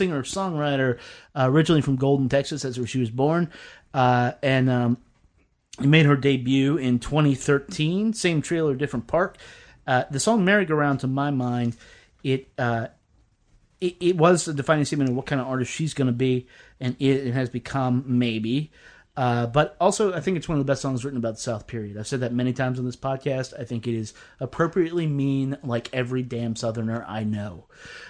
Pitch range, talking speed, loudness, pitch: 125-150 Hz, 190 wpm, -24 LUFS, 135 Hz